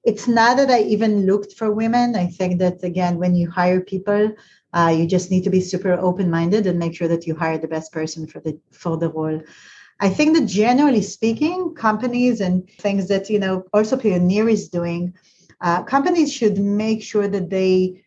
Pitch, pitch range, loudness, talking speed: 190 Hz, 180-220 Hz, -19 LUFS, 200 wpm